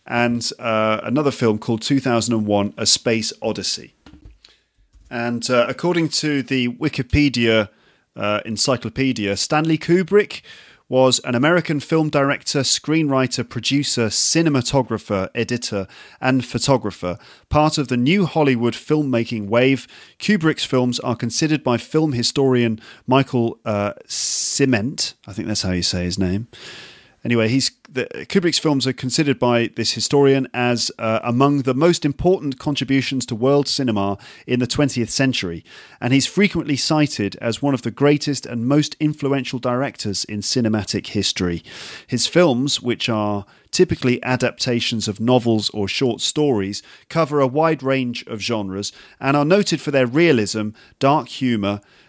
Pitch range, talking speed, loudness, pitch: 115-145 Hz, 140 wpm, -19 LUFS, 125 Hz